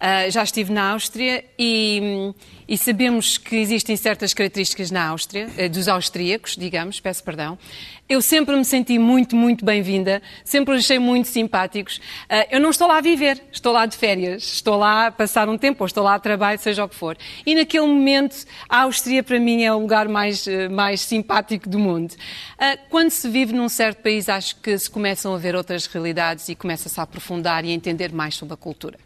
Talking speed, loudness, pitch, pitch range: 205 wpm, -19 LUFS, 210 Hz, 190-240 Hz